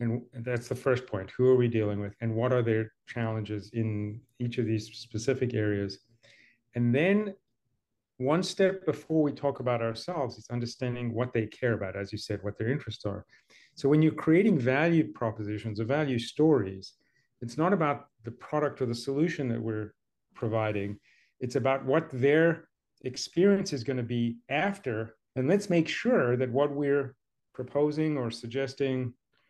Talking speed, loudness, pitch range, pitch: 170 wpm, -29 LUFS, 115-145 Hz, 125 Hz